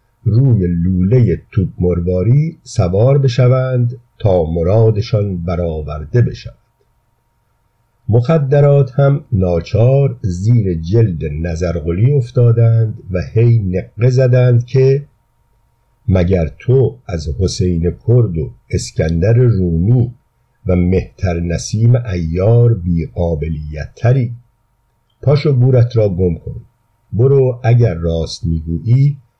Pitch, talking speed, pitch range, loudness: 115 Hz, 95 wpm, 90-125 Hz, -14 LUFS